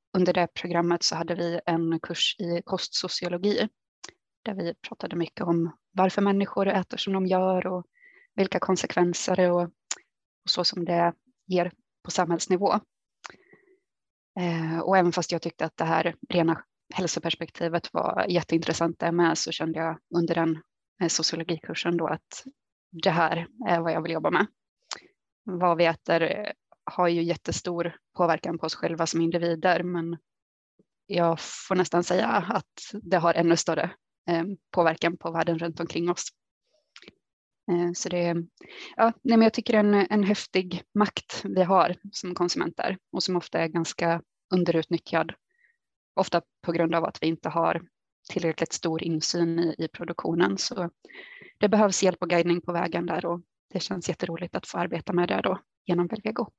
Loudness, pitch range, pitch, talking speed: -26 LUFS, 170-190 Hz, 175 Hz, 155 wpm